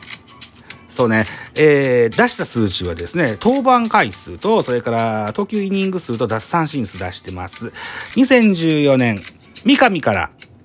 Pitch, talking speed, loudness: 135 Hz, 255 characters per minute, -16 LUFS